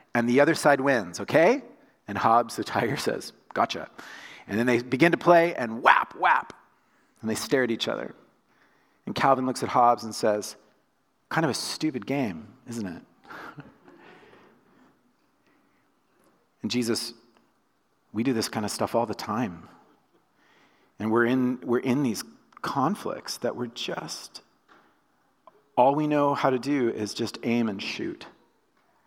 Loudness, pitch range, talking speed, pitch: -26 LUFS, 115-135 Hz, 150 wpm, 120 Hz